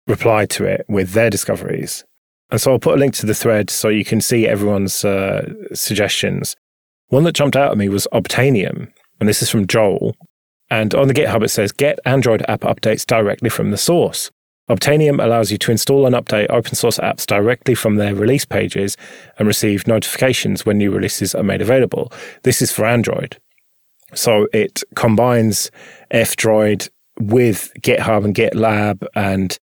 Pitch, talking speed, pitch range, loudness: 110 Hz, 175 wpm, 105-120 Hz, -16 LUFS